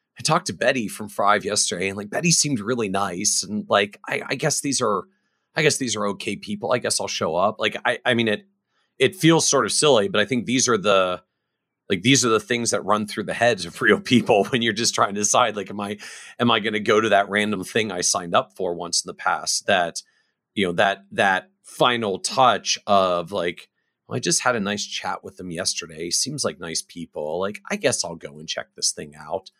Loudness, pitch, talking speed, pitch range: -21 LUFS, 110 Hz, 240 wpm, 100-135 Hz